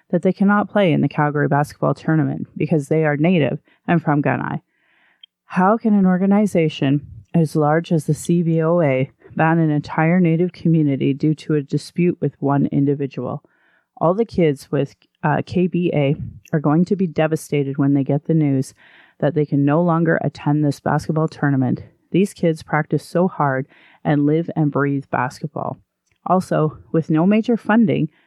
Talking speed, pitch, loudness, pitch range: 165 wpm, 155 Hz, -19 LUFS, 145-175 Hz